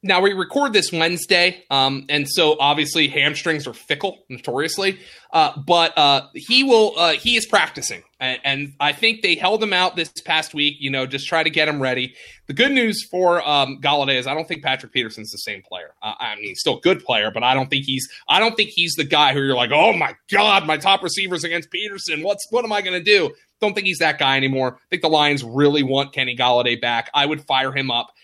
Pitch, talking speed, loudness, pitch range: 155 Hz, 235 wpm, -18 LUFS, 135-195 Hz